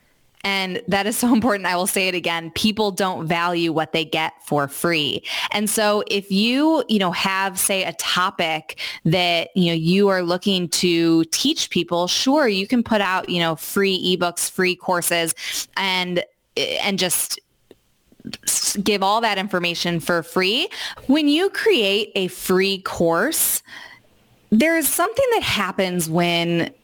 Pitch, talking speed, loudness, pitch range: 185 Hz, 155 wpm, -20 LUFS, 175-210 Hz